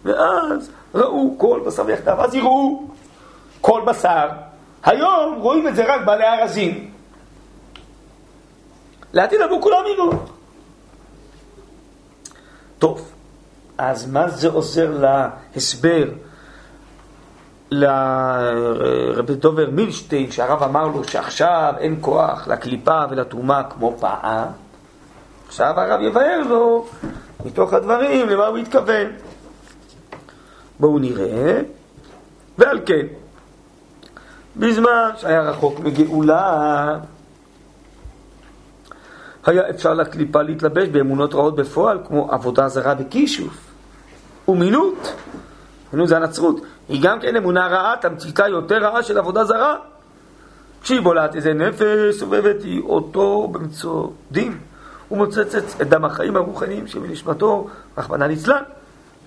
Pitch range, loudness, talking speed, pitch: 145-230 Hz, -18 LUFS, 100 wpm, 165 Hz